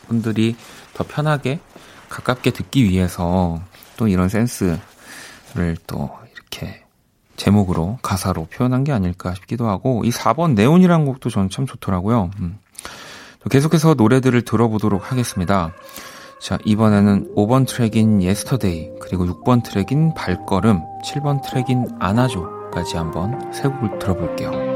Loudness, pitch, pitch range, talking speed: -19 LUFS, 110 Hz, 95-130 Hz, 295 characters per minute